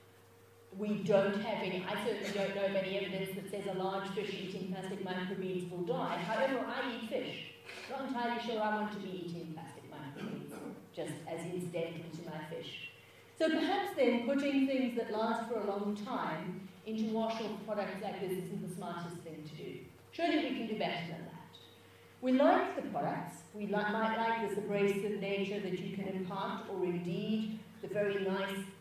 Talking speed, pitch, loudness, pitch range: 190 wpm, 200 Hz, -36 LUFS, 185-220 Hz